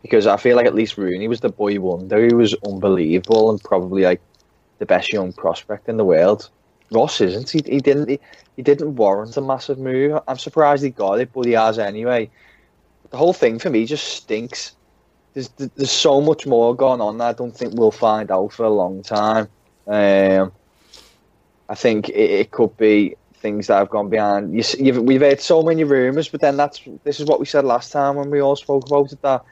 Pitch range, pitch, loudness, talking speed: 105-140 Hz, 120 Hz, -18 LUFS, 220 wpm